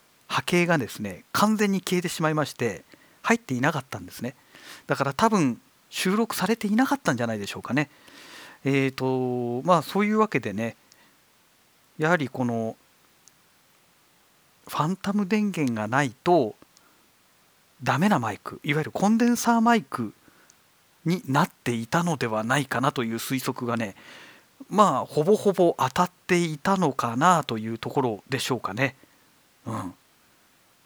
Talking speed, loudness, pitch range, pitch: 300 characters per minute, -25 LUFS, 125-185 Hz, 150 Hz